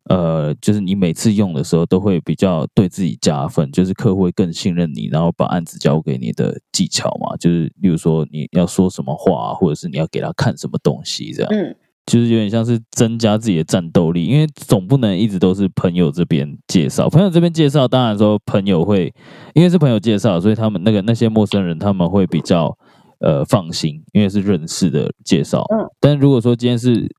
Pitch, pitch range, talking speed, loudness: 105 Hz, 85-120 Hz, 330 characters per minute, -16 LUFS